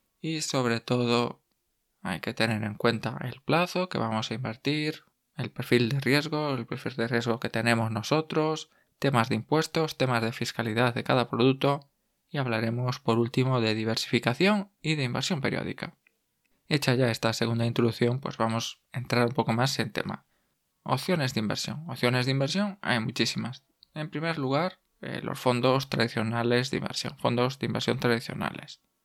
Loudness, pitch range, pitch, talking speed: -28 LUFS, 115-145 Hz, 125 Hz, 160 wpm